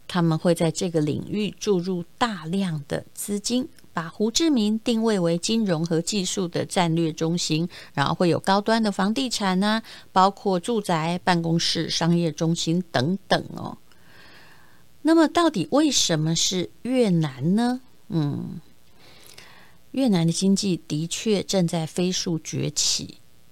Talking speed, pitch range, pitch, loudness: 210 characters per minute, 165-210 Hz, 180 Hz, -23 LUFS